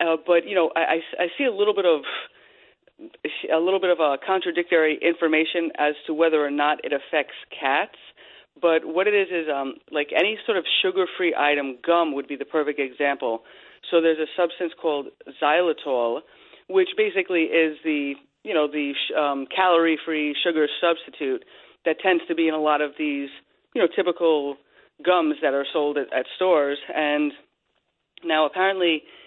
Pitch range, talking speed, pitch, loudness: 150-180 Hz, 170 wpm, 165 Hz, -23 LUFS